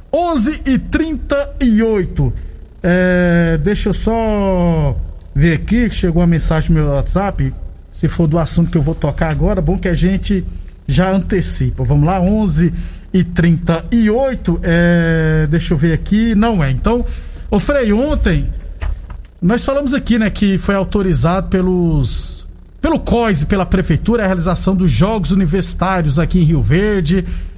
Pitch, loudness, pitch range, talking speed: 180 Hz, -14 LUFS, 155-205 Hz, 150 wpm